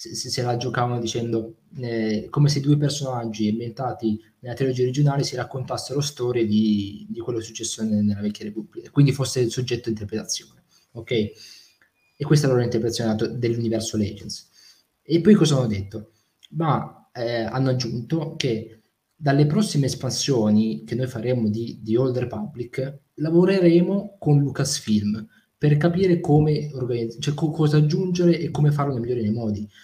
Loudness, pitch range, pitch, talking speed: -23 LUFS, 110-145 Hz, 125 Hz, 155 wpm